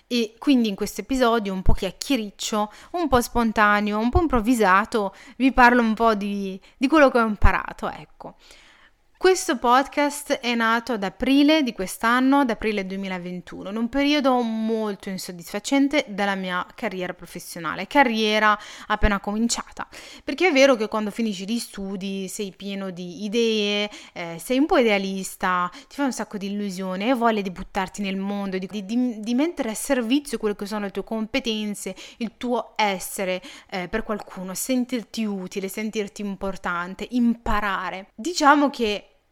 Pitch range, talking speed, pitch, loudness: 195-250 Hz, 155 wpm, 215 Hz, -23 LUFS